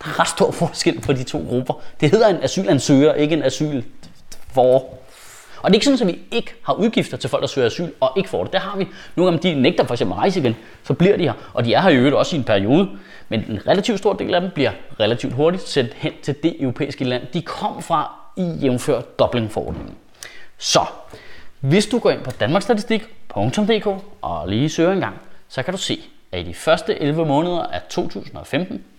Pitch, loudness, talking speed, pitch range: 155 Hz, -19 LUFS, 220 wpm, 135-190 Hz